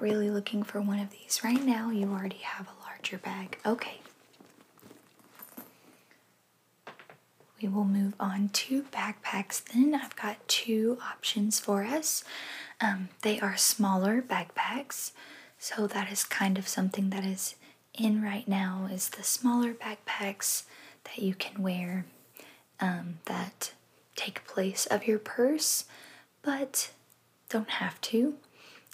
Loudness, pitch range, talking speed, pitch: -31 LUFS, 195-235 Hz, 130 wpm, 210 Hz